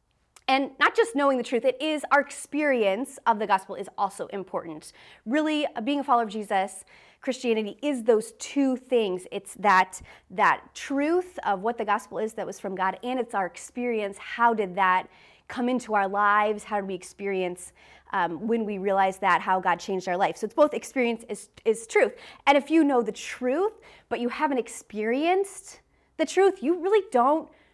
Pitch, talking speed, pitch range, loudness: 235 Hz, 190 wpm, 200-280 Hz, -26 LUFS